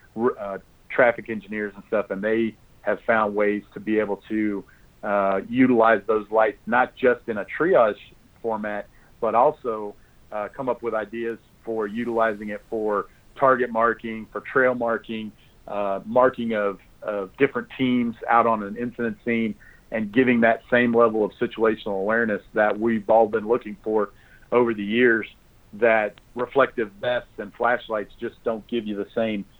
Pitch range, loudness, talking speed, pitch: 105-115 Hz, -23 LUFS, 160 wpm, 110 Hz